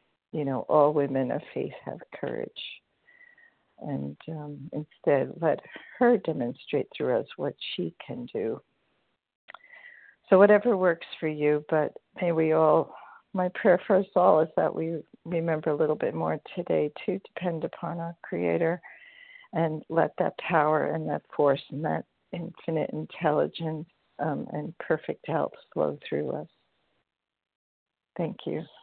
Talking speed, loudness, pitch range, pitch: 140 wpm, -28 LUFS, 150-190 Hz, 165 Hz